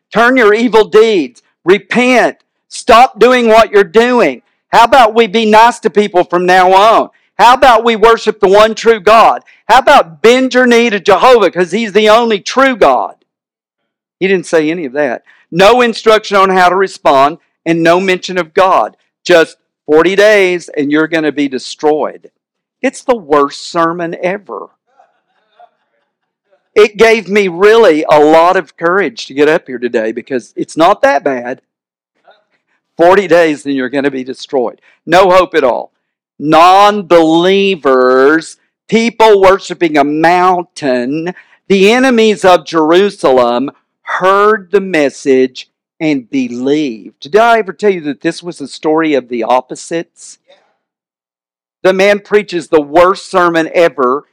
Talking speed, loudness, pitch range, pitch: 150 wpm, -9 LUFS, 150-215 Hz, 180 Hz